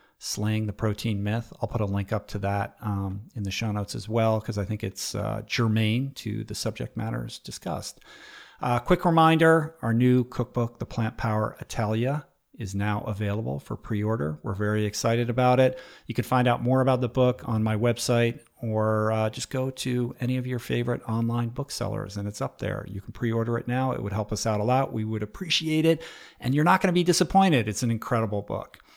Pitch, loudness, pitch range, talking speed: 115 Hz, -26 LUFS, 105-125 Hz, 215 wpm